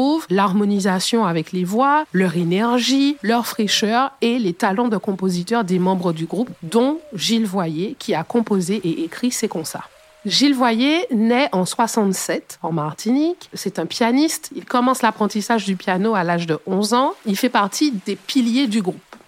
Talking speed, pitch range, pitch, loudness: 170 wpm, 185-245 Hz, 215 Hz, -19 LUFS